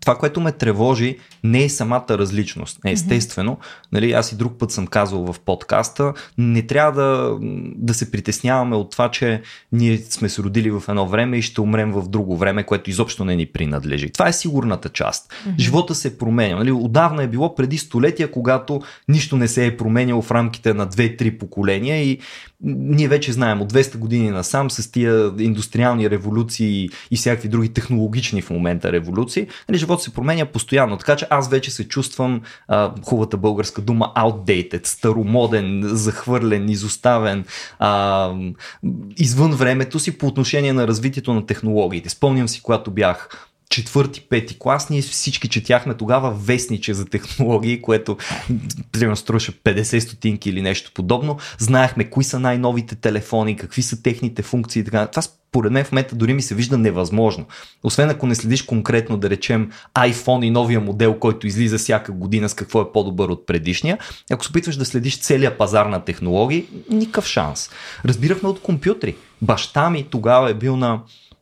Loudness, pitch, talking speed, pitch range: -19 LUFS, 115 Hz, 165 wpm, 105-130 Hz